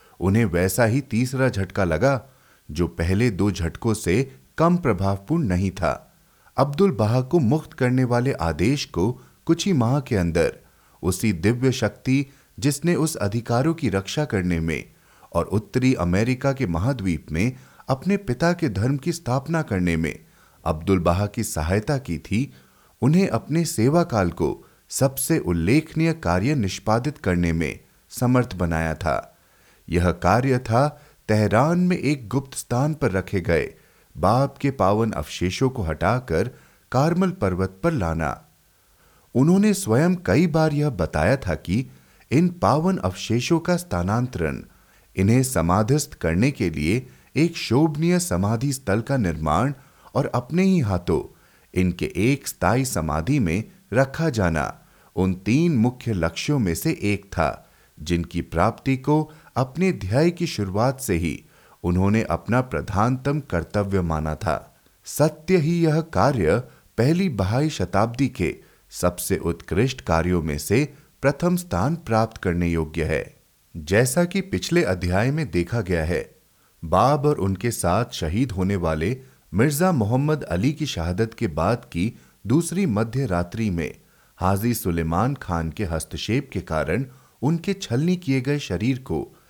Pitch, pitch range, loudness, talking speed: 115 Hz, 90-145 Hz, -23 LUFS, 140 wpm